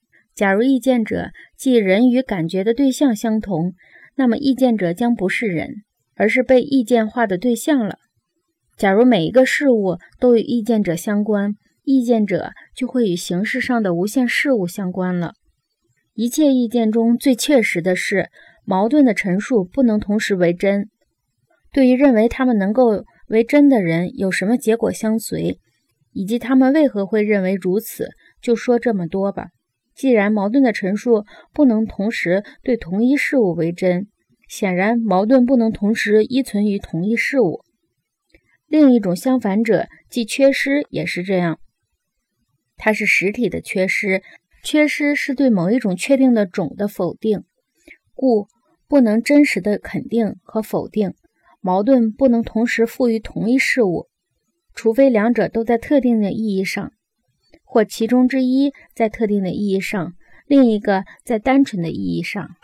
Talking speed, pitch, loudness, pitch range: 235 characters per minute, 225 Hz, -18 LUFS, 195-255 Hz